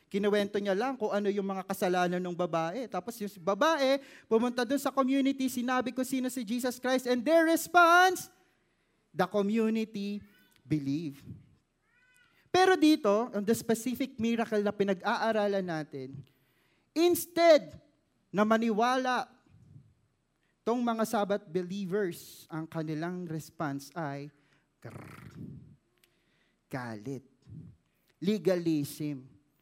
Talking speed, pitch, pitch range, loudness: 105 wpm, 205 Hz, 165-255 Hz, -30 LUFS